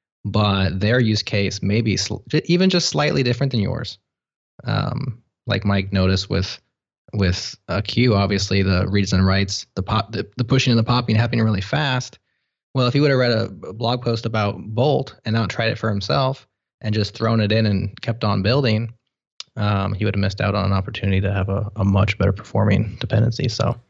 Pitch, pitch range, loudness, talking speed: 110 Hz, 100-125 Hz, -20 LUFS, 205 wpm